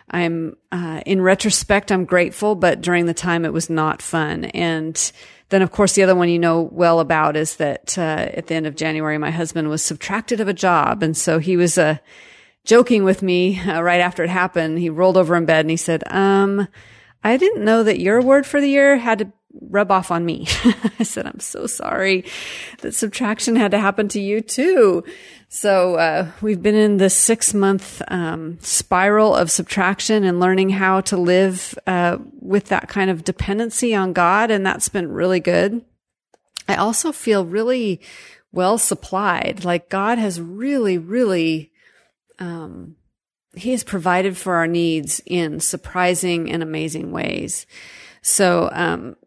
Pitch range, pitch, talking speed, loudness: 170-210 Hz, 185 Hz, 175 wpm, -18 LUFS